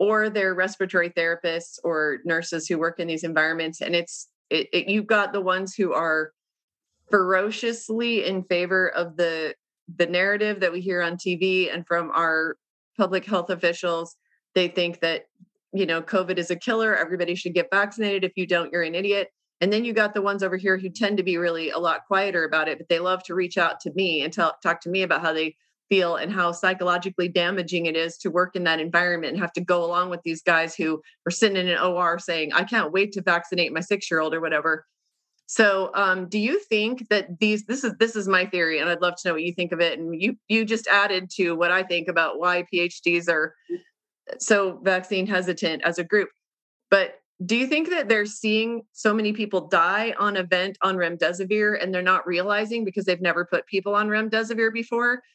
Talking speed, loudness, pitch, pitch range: 215 wpm, -23 LUFS, 185 Hz, 170-205 Hz